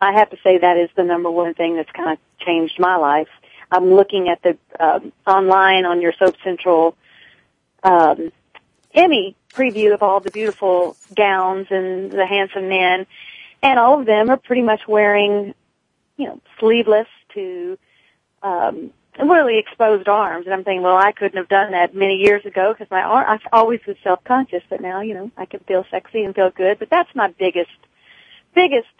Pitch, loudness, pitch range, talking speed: 195 Hz, -16 LUFS, 185-215 Hz, 185 wpm